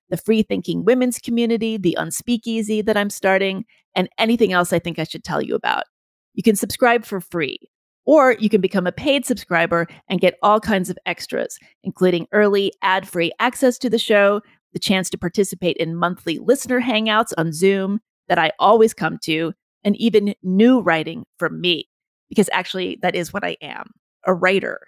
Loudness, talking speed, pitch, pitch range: -19 LUFS, 180 wpm, 200 Hz, 180-225 Hz